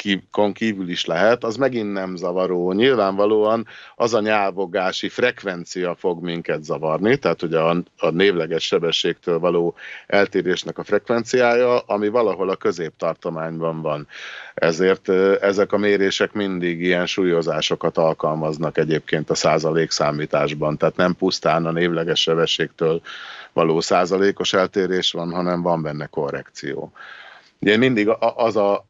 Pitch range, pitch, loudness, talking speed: 85-100 Hz, 90 Hz, -20 LUFS, 125 wpm